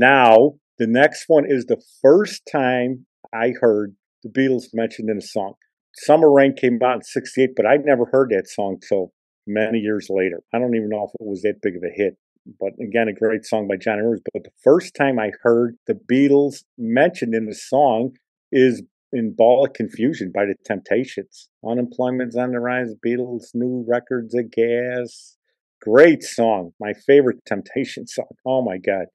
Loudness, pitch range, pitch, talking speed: -19 LUFS, 110-125 Hz, 120 Hz, 185 wpm